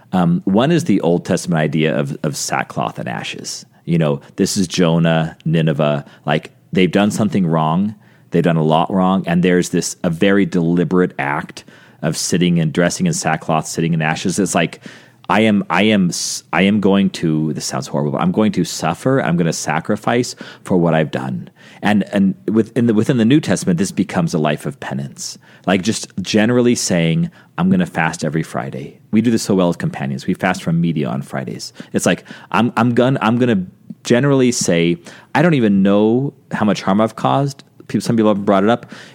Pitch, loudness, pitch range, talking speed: 95 Hz, -17 LUFS, 80-115 Hz, 200 wpm